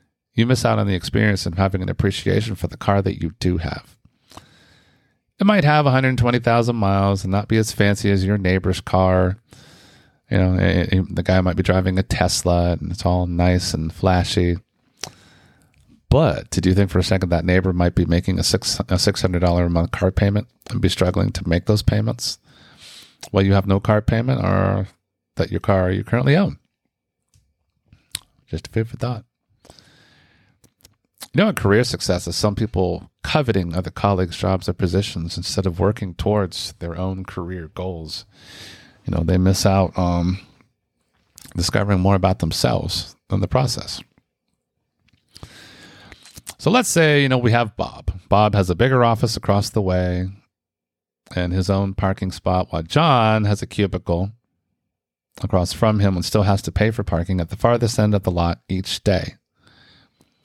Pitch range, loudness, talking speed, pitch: 90-105 Hz, -20 LUFS, 170 wpm, 95 Hz